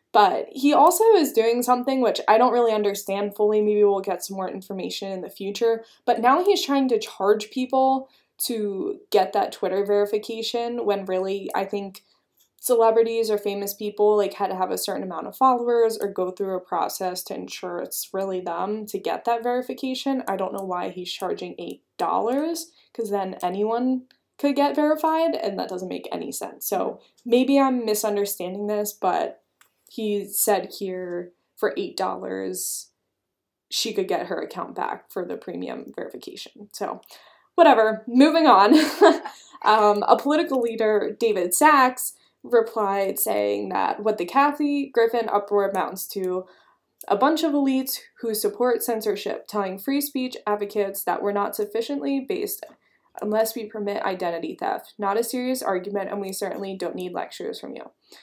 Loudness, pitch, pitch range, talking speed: -23 LUFS, 215 Hz, 200-260 Hz, 160 wpm